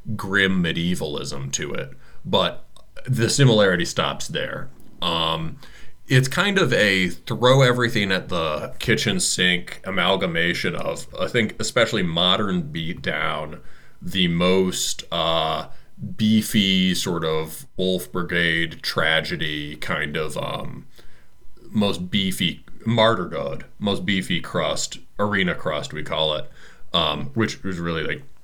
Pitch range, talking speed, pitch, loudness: 85-115 Hz, 120 wpm, 95 Hz, -22 LUFS